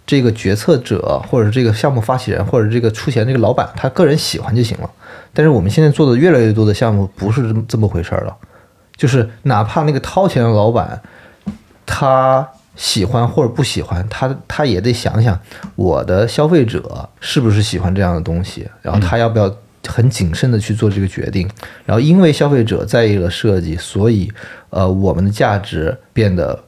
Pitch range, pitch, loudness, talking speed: 100-130 Hz, 110 Hz, -14 LUFS, 305 characters per minute